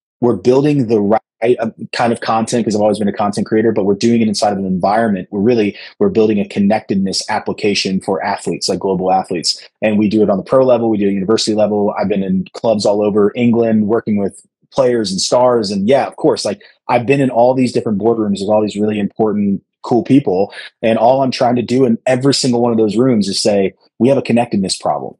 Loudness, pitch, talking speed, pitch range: -14 LUFS, 110 Hz, 235 wpm, 100-120 Hz